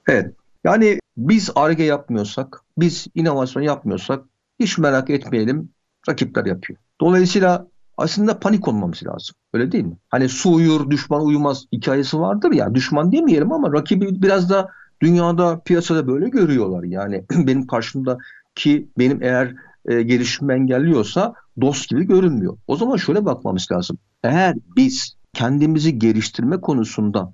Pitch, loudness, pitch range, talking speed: 145 Hz, -18 LUFS, 125-175 Hz, 130 wpm